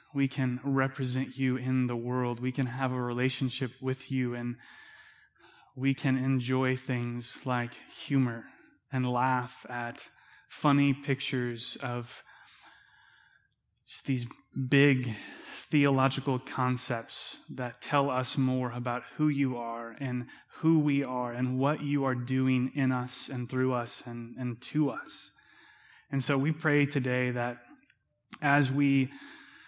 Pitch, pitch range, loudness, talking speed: 130 Hz, 125-140 Hz, -30 LUFS, 135 wpm